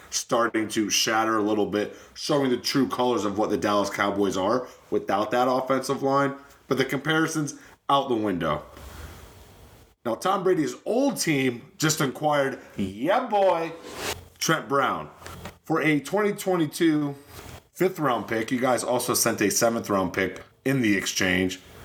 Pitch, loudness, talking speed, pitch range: 125 Hz, -25 LUFS, 150 wpm, 105-145 Hz